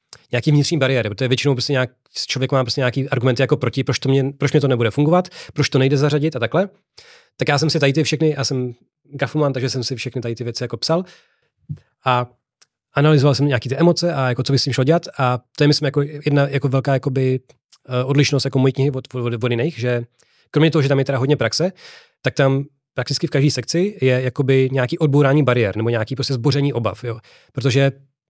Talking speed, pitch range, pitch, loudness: 225 wpm, 130-145 Hz, 135 Hz, -19 LUFS